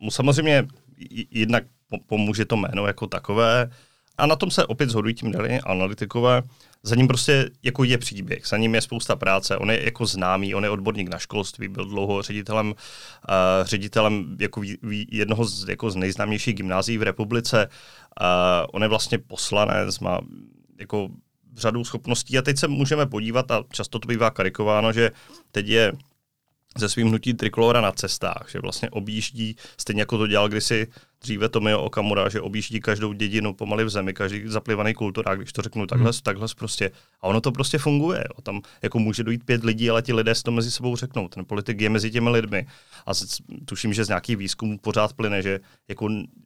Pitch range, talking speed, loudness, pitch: 105-120 Hz, 185 wpm, -23 LUFS, 110 Hz